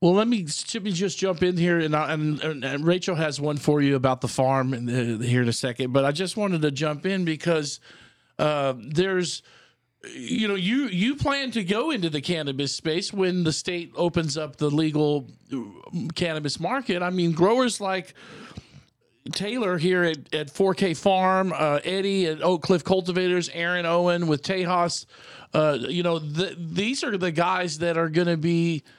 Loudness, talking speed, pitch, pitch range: -24 LUFS, 185 wpm, 170 Hz, 150-190 Hz